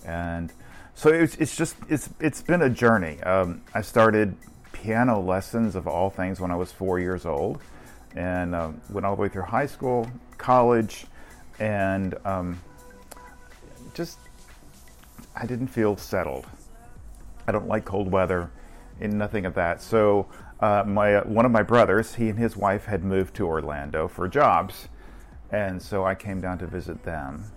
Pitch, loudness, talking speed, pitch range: 95 Hz, -25 LUFS, 165 wpm, 90-110 Hz